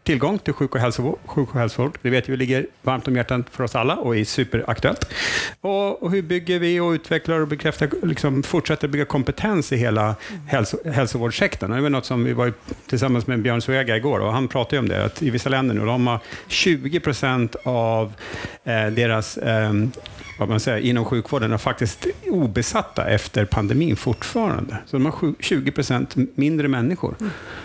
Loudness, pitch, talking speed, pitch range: -22 LUFS, 130 Hz, 180 wpm, 115-145 Hz